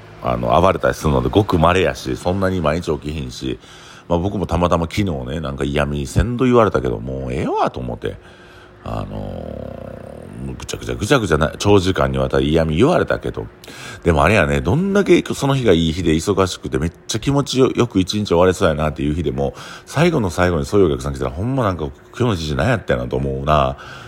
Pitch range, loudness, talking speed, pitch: 70-110 Hz, -18 LUFS, 430 characters per minute, 85 Hz